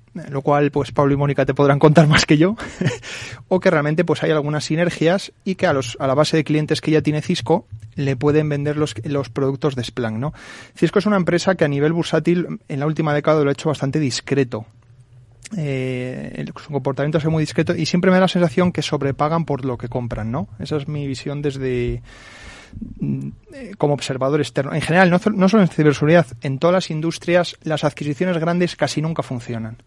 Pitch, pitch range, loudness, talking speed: 150 Hz, 135-165 Hz, -19 LUFS, 205 wpm